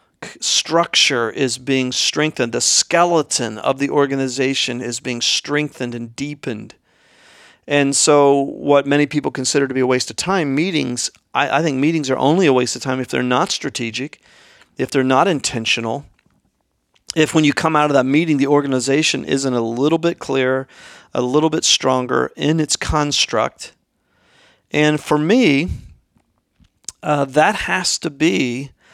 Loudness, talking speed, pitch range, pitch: -17 LUFS, 155 wpm, 125-150 Hz, 135 Hz